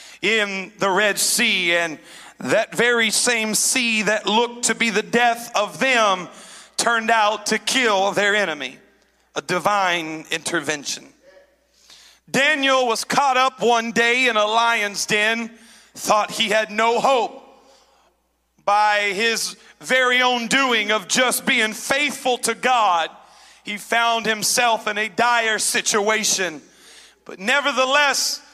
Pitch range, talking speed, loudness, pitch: 205-245 Hz, 130 wpm, -19 LUFS, 225 Hz